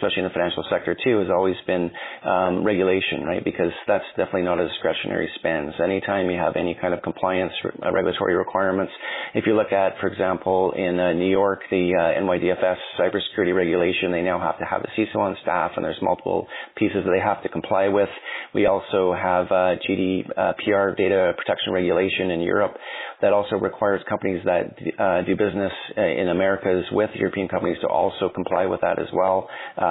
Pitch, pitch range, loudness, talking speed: 95 Hz, 90-95 Hz, -22 LUFS, 190 wpm